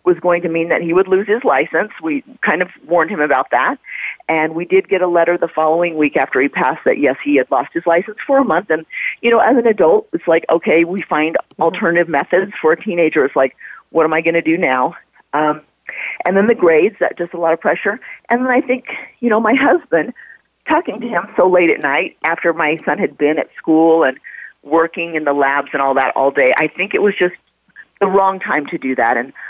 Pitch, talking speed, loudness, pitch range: 170 Hz, 240 wpm, -15 LUFS, 155-200 Hz